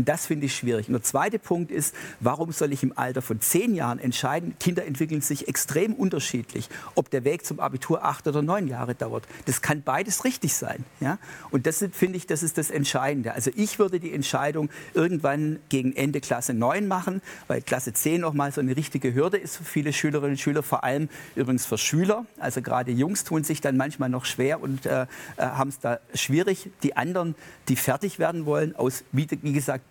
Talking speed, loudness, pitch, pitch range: 205 wpm, -26 LUFS, 145 Hz, 130-165 Hz